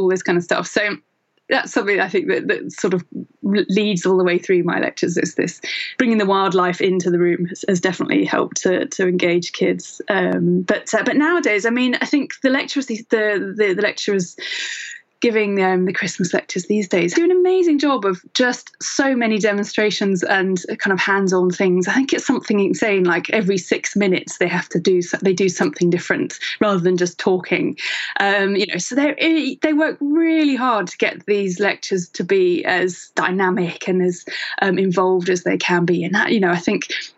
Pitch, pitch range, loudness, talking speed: 195 Hz, 185-245 Hz, -18 LUFS, 205 wpm